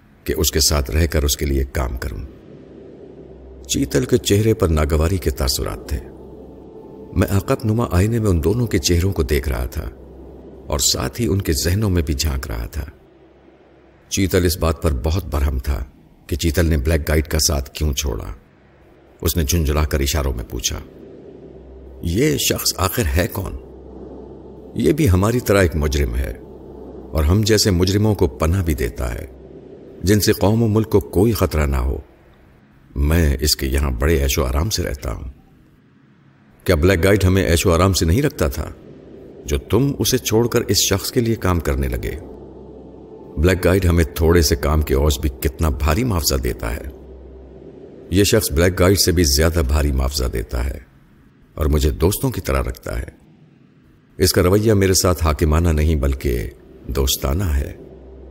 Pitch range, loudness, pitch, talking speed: 70-95 Hz, -18 LUFS, 80 Hz, 180 wpm